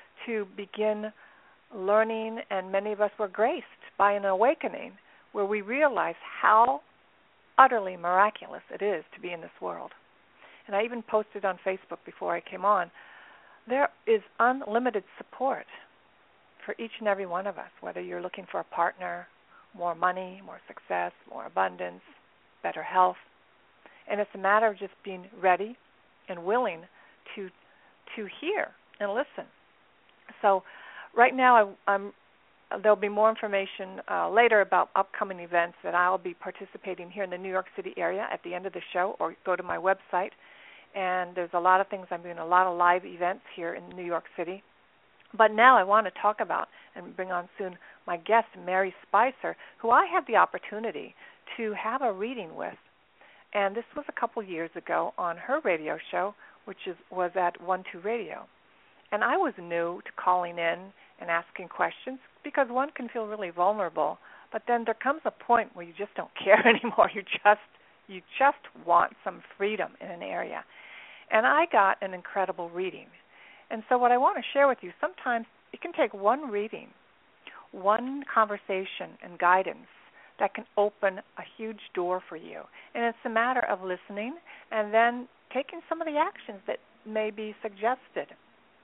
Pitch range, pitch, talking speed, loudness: 185-230 Hz, 205 Hz, 175 wpm, -28 LUFS